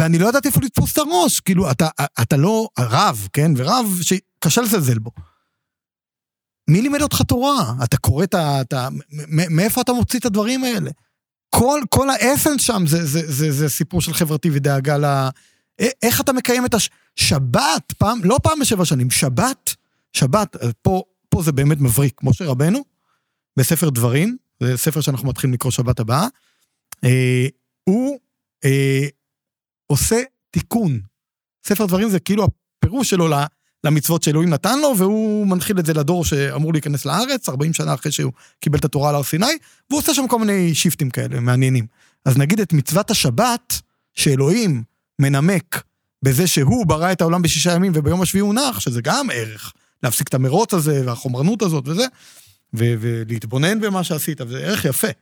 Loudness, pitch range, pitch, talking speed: -18 LUFS, 135-205 Hz, 155 Hz, 165 wpm